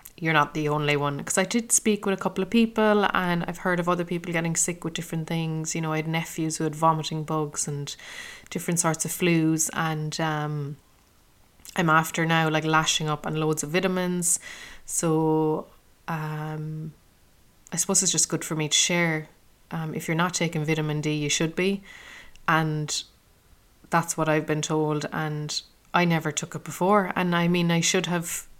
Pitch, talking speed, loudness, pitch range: 160 Hz, 190 wpm, -25 LUFS, 155-175 Hz